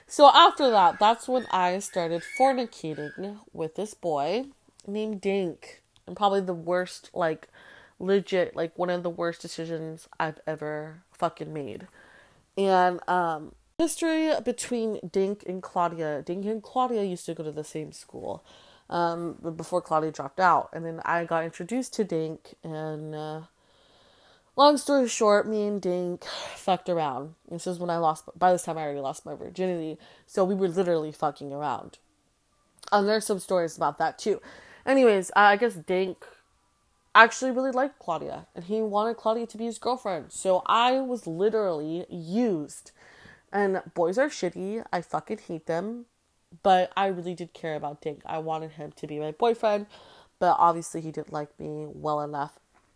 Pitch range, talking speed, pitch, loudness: 160-210 Hz, 165 wpm, 180 Hz, -27 LUFS